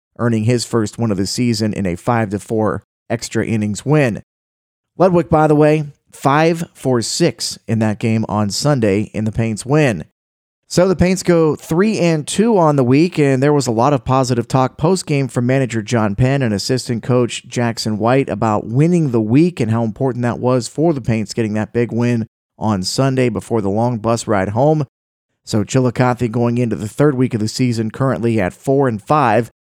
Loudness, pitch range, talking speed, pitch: -16 LUFS, 110-140 Hz, 195 wpm, 120 Hz